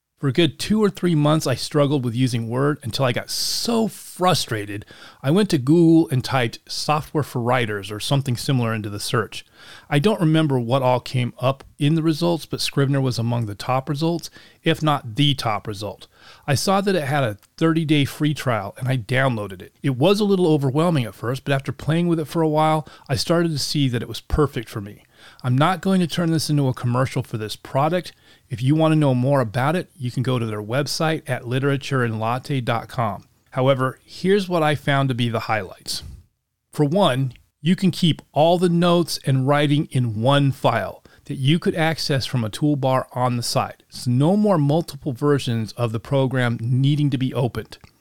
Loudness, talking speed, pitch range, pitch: -21 LUFS, 205 wpm, 120-155 Hz, 135 Hz